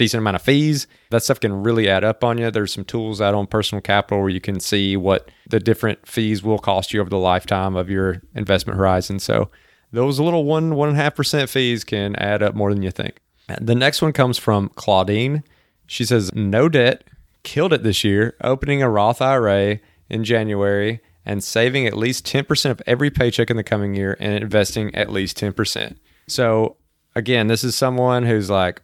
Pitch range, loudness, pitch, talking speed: 100-125 Hz, -19 LUFS, 110 Hz, 205 wpm